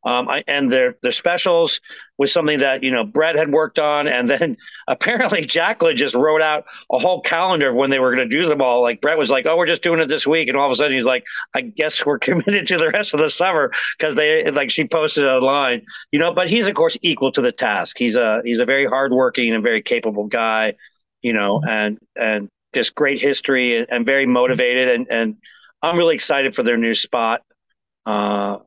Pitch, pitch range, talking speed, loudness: 140 Hz, 125-165 Hz, 225 wpm, -17 LUFS